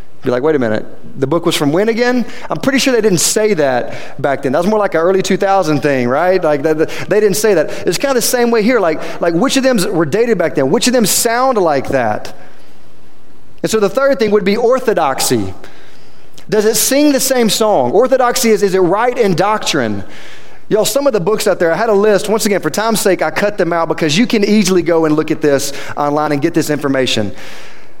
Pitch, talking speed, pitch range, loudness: 200 Hz, 240 wpm, 160-230 Hz, -13 LUFS